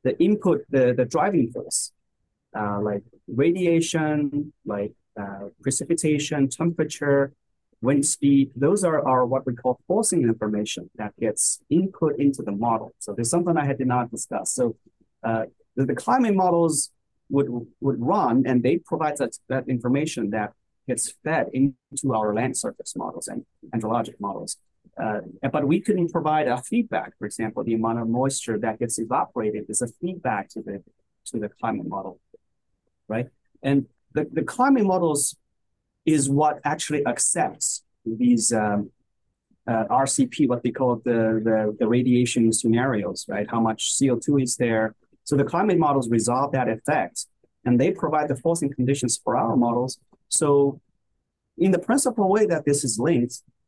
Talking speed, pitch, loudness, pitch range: 160 wpm, 130 Hz, -23 LUFS, 115-150 Hz